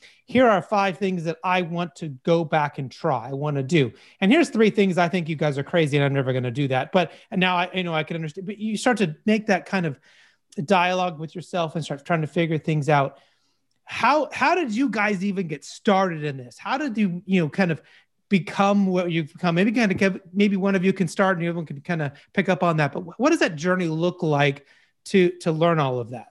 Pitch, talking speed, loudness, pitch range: 175 Hz, 260 wpm, -23 LUFS, 155-195 Hz